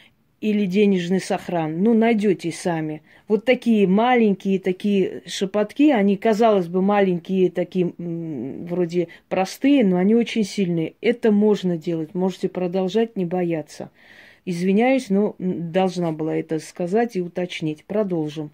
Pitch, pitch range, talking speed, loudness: 190 Hz, 175-210 Hz, 125 wpm, -21 LUFS